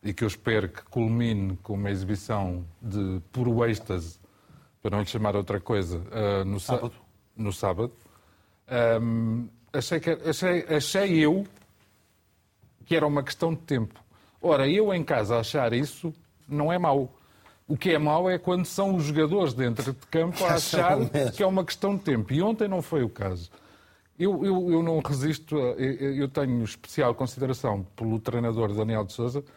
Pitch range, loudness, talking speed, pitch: 105-155 Hz, -27 LUFS, 175 wpm, 120 Hz